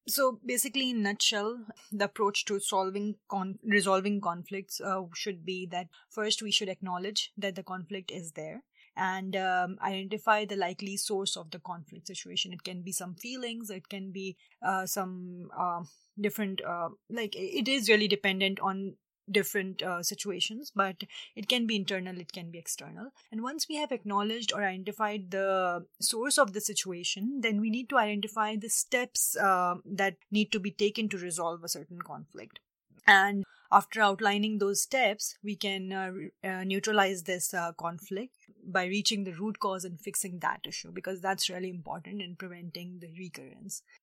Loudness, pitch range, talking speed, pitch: -31 LUFS, 185-210 Hz, 170 wpm, 195 Hz